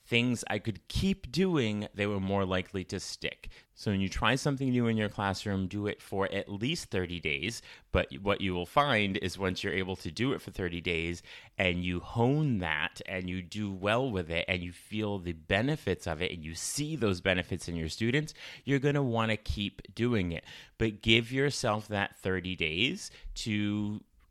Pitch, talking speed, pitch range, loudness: 100 Hz, 200 wpm, 90-115 Hz, -32 LUFS